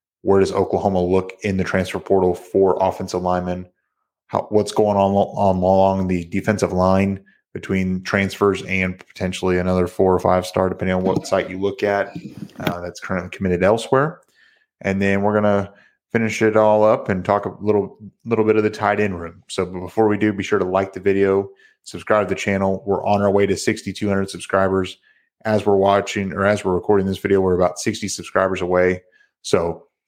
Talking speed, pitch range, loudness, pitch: 195 wpm, 95-100 Hz, -19 LUFS, 95 Hz